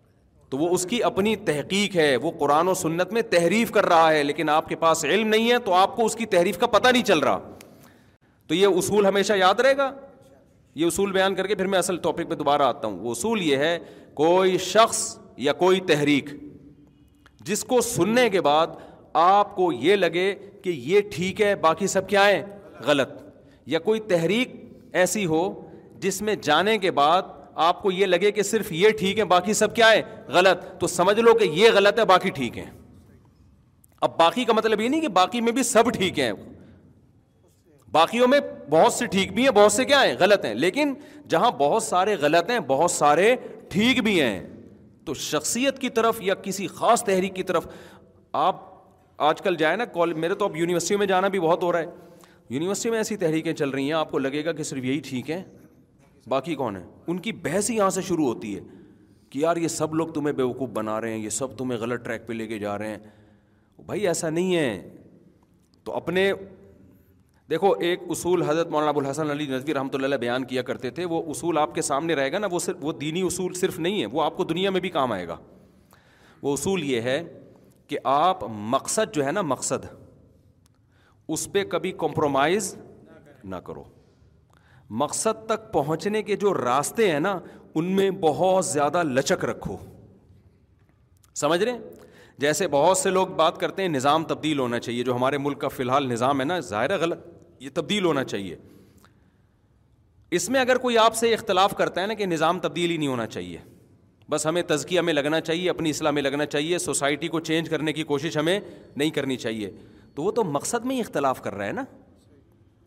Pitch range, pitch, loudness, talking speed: 140-200 Hz, 170 Hz, -23 LUFS, 205 wpm